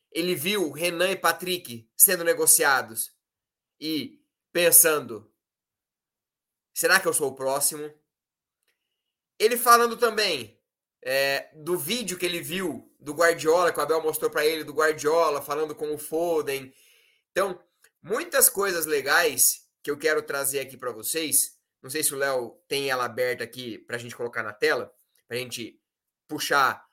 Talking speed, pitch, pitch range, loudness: 150 wpm, 160 Hz, 145-200 Hz, -23 LUFS